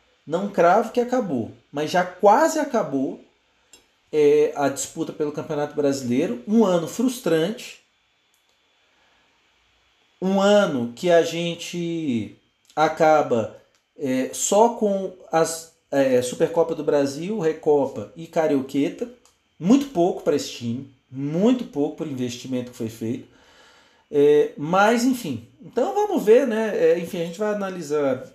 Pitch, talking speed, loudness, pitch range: 170 Hz, 125 wpm, -22 LUFS, 150-225 Hz